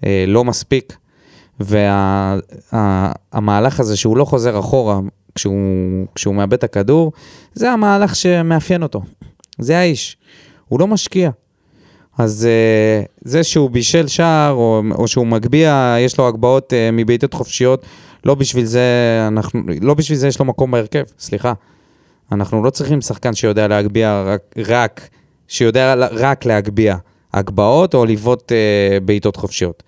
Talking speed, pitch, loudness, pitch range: 135 wpm, 120 Hz, -15 LUFS, 105-135 Hz